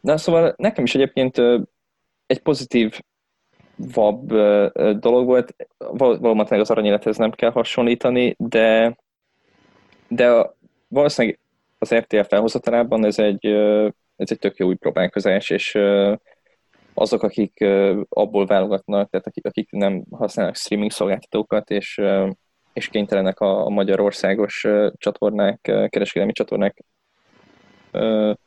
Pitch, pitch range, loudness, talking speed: 105 Hz, 100-120 Hz, -19 LUFS, 105 wpm